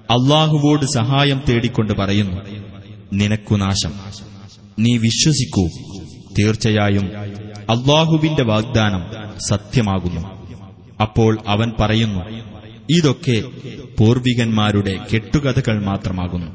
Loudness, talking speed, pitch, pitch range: -17 LUFS, 70 wpm, 110 Hz, 100-120 Hz